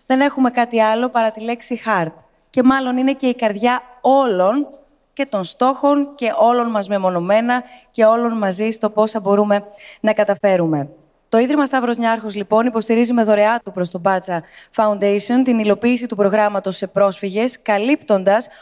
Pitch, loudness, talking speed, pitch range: 220 Hz, -17 LUFS, 160 wpm, 205-250 Hz